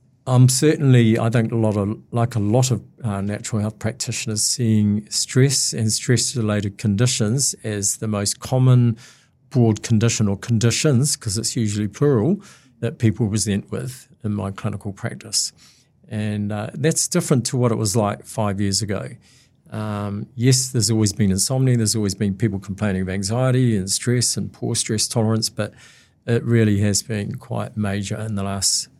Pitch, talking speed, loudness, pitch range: 110 Hz, 170 wpm, -20 LUFS, 105-125 Hz